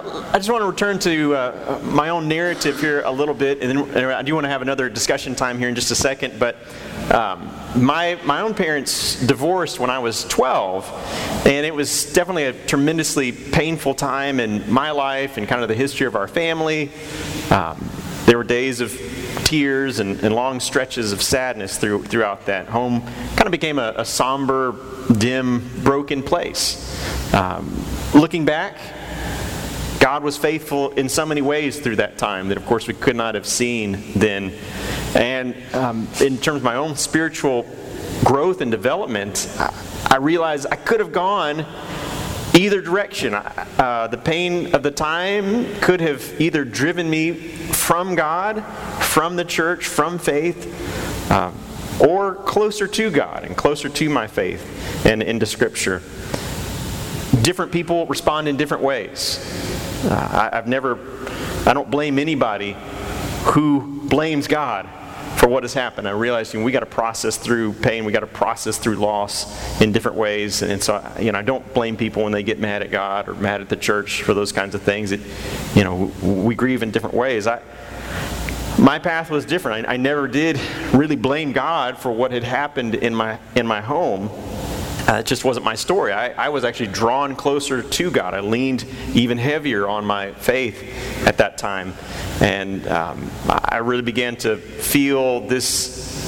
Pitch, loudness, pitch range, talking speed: 130 Hz, -20 LUFS, 115-150 Hz, 175 wpm